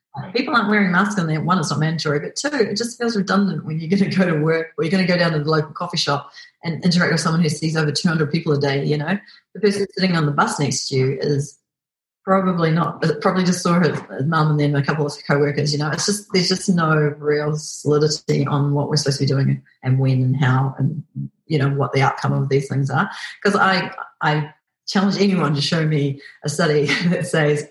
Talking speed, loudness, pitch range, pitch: 245 wpm, -19 LUFS, 145-185 Hz, 155 Hz